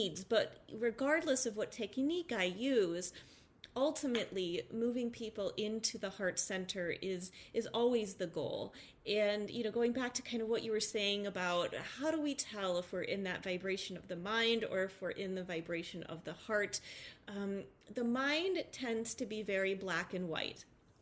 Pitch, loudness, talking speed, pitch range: 210 Hz, -37 LUFS, 185 wpm, 185-235 Hz